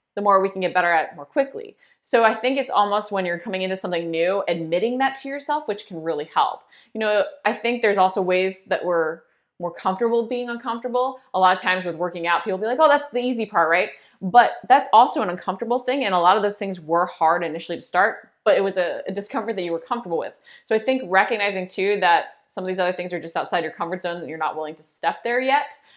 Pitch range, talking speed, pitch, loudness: 175-240 Hz, 255 wpm, 195 Hz, -22 LUFS